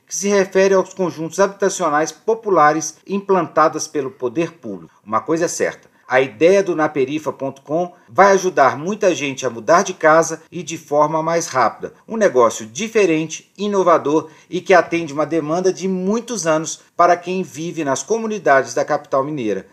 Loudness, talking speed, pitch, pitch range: -17 LUFS, 160 wpm, 165 Hz, 155-190 Hz